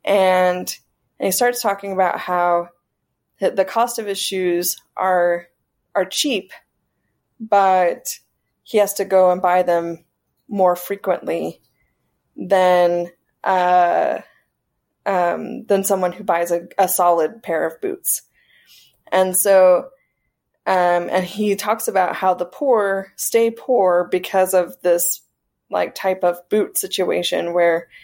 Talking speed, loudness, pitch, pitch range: 125 wpm, -19 LUFS, 185 Hz, 175-200 Hz